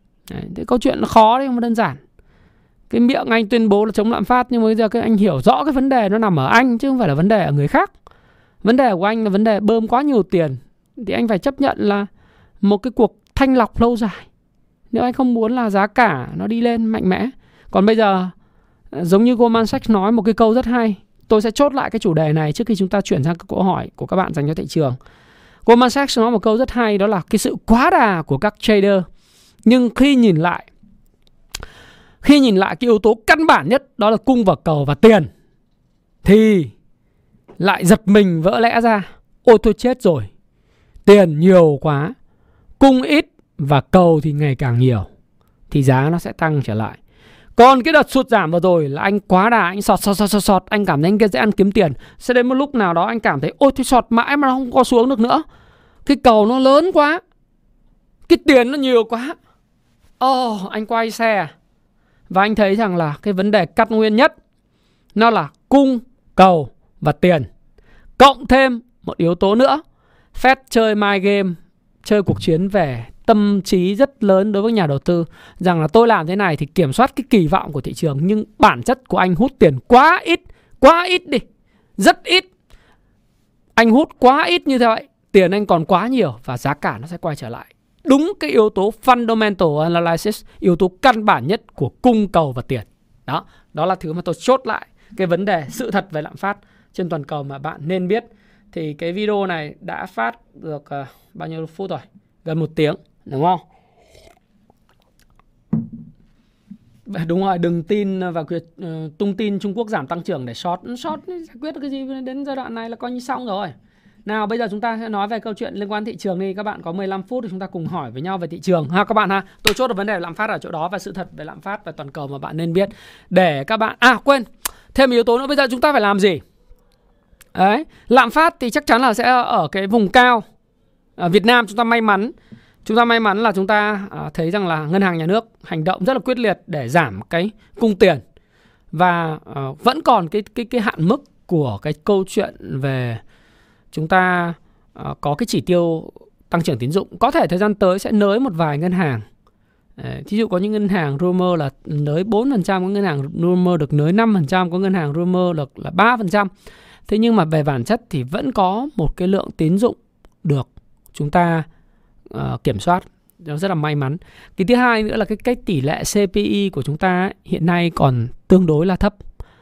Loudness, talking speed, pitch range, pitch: -16 LUFS, 225 wpm, 170-235 Hz, 205 Hz